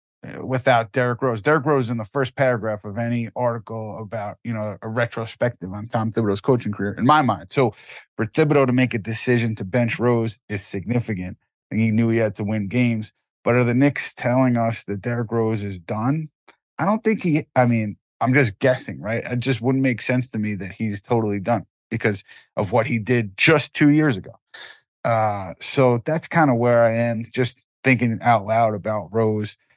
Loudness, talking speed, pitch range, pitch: -21 LUFS, 200 wpm, 110-130 Hz, 115 Hz